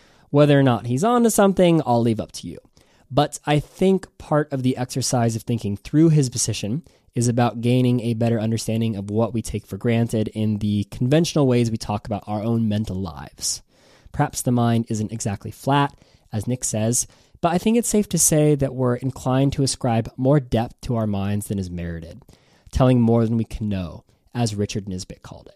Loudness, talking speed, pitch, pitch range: -21 LUFS, 200 wpm, 120 Hz, 110-135 Hz